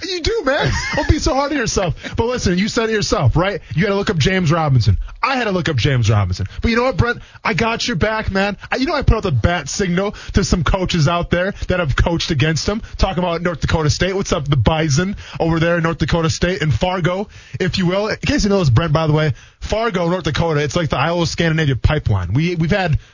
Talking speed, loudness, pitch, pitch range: 260 wpm, -17 LUFS, 175 Hz, 150-200 Hz